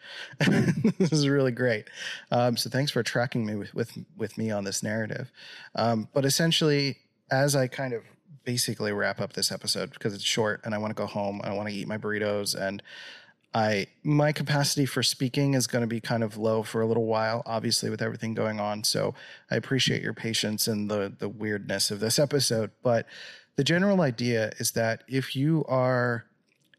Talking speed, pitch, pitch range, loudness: 195 wpm, 115 Hz, 110-135 Hz, -27 LUFS